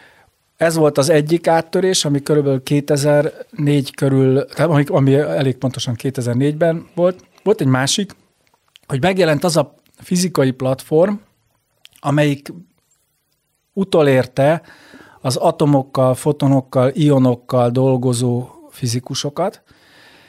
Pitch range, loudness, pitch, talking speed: 130-160 Hz, -17 LUFS, 145 Hz, 95 wpm